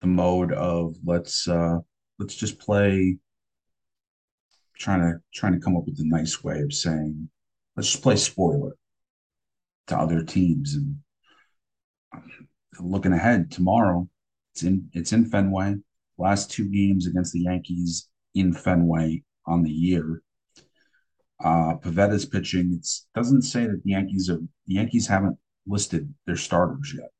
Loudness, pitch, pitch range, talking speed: -24 LUFS, 90 Hz, 85-100 Hz, 140 wpm